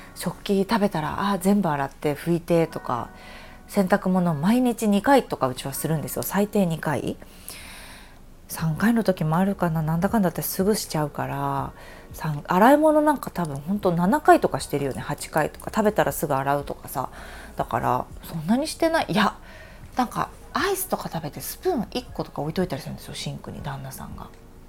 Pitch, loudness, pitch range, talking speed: 175 Hz, -24 LUFS, 145-205 Hz, 350 characters per minute